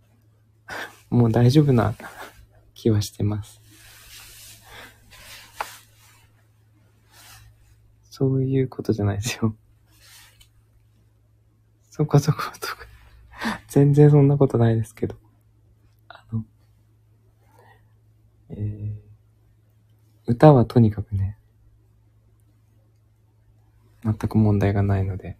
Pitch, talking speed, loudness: 110 Hz, 150 characters per minute, -21 LUFS